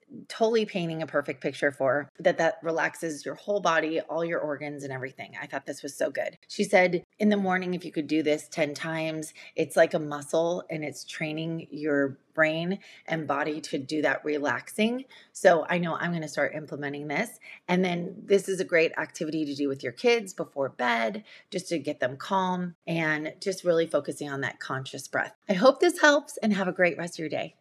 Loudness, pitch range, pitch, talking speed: -28 LUFS, 150-185 Hz, 165 Hz, 215 wpm